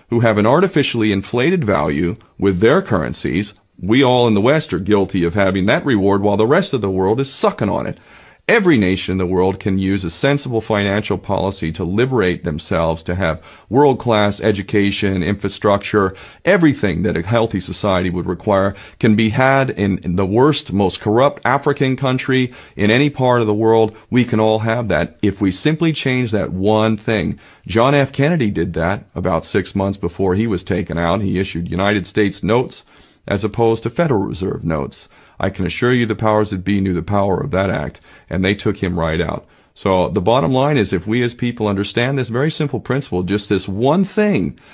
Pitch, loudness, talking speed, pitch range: 105 Hz, -17 LUFS, 195 wpm, 95-120 Hz